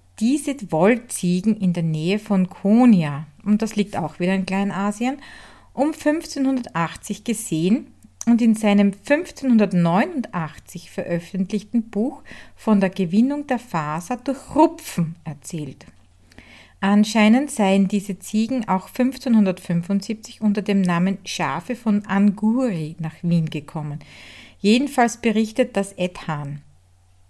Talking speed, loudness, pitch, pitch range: 110 wpm, -21 LUFS, 200 Hz, 170-235 Hz